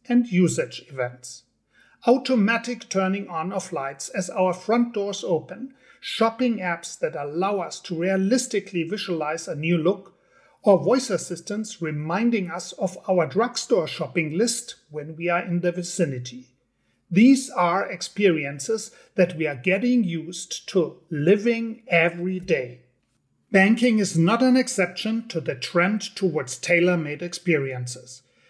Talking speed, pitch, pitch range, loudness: 135 wpm, 180 Hz, 160-220 Hz, -23 LUFS